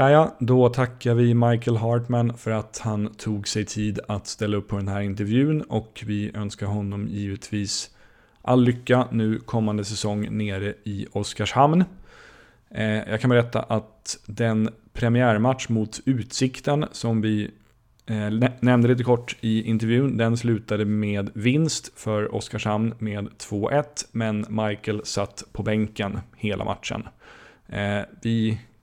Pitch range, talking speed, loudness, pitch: 105-120 Hz, 130 wpm, -24 LUFS, 110 Hz